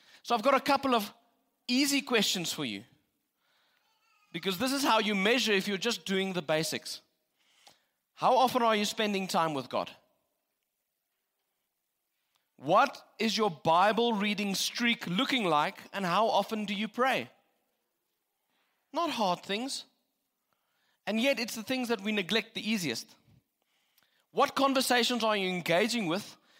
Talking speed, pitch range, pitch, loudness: 140 wpm, 195-250 Hz, 220 Hz, -29 LUFS